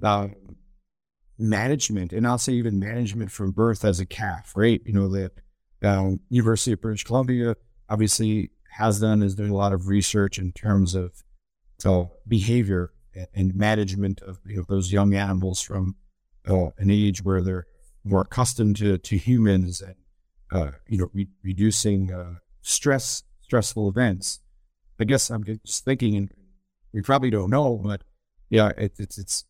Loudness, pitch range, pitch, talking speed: -24 LUFS, 95-110 Hz, 100 Hz, 165 wpm